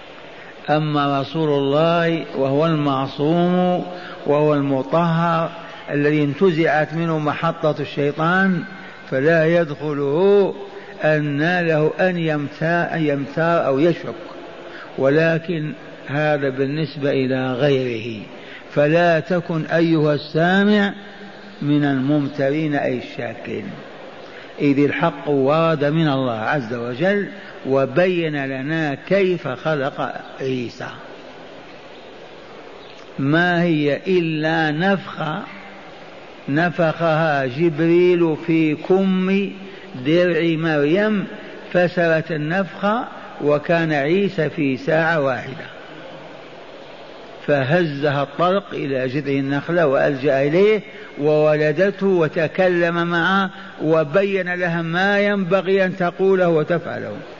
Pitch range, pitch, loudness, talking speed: 145-180 Hz, 160 Hz, -19 LUFS, 85 wpm